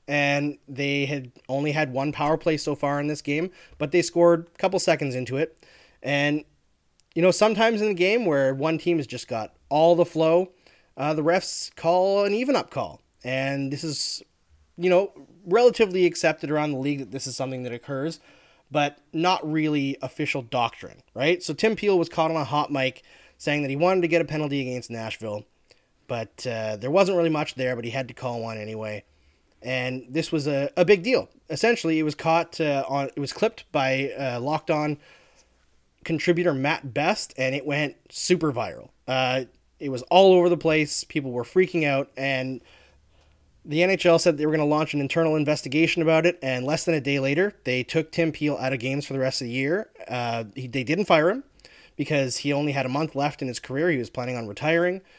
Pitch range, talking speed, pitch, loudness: 130-165 Hz, 210 wpm, 145 Hz, -24 LUFS